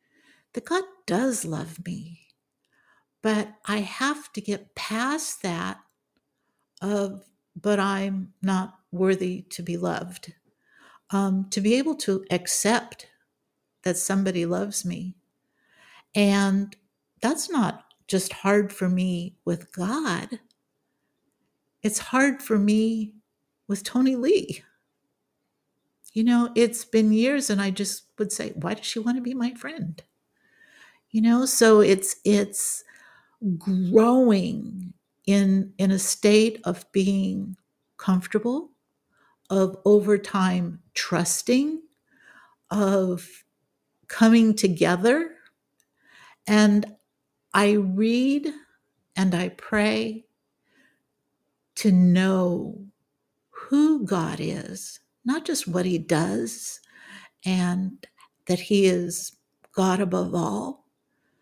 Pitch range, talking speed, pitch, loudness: 185-225 Hz, 105 wpm, 200 Hz, -24 LUFS